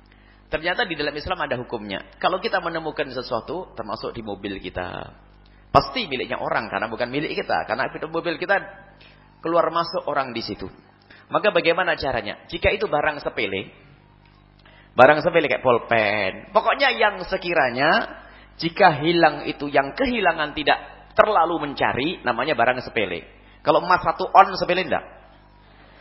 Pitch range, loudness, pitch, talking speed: 115-180 Hz, -22 LUFS, 155 Hz, 140 wpm